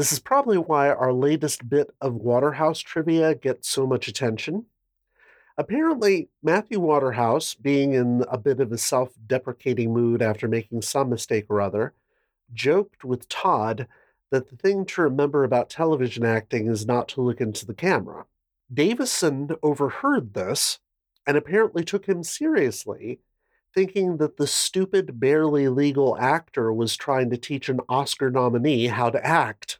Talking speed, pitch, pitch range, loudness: 150 wpm, 135 Hz, 120-160 Hz, -23 LUFS